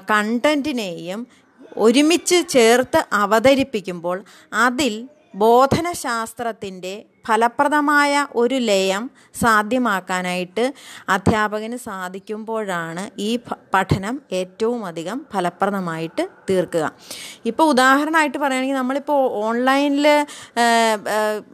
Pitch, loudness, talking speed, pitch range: 230 Hz, -19 LUFS, 65 wpm, 200-270 Hz